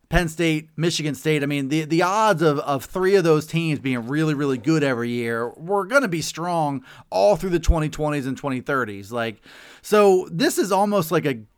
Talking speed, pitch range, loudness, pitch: 205 wpm, 135-175 Hz, -21 LUFS, 155 Hz